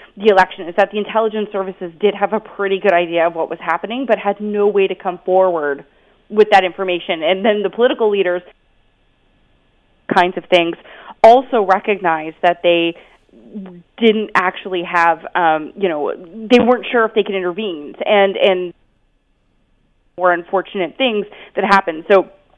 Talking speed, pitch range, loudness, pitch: 160 wpm, 180-210 Hz, -16 LUFS, 195 Hz